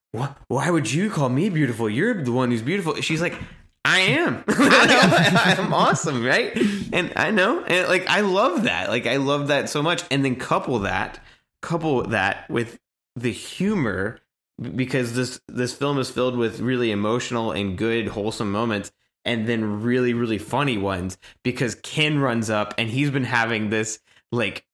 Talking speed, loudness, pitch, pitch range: 175 wpm, -22 LUFS, 125 Hz, 115-140 Hz